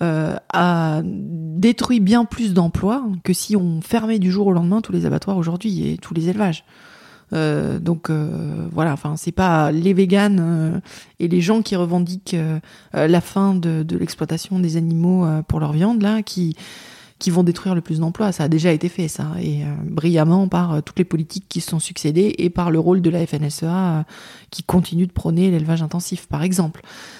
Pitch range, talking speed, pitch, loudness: 160-190 Hz, 200 wpm, 175 Hz, -19 LUFS